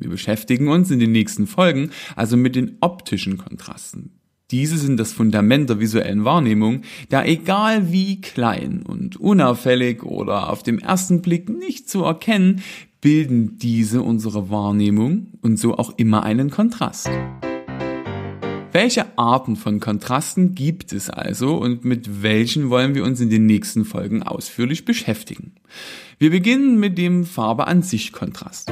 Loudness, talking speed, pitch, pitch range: -19 LUFS, 145 wpm, 125 Hz, 110-175 Hz